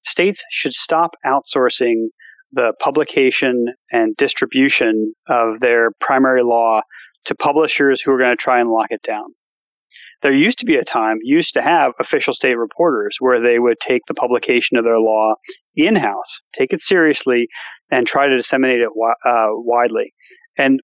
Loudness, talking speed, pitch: -16 LUFS, 165 wpm, 130 Hz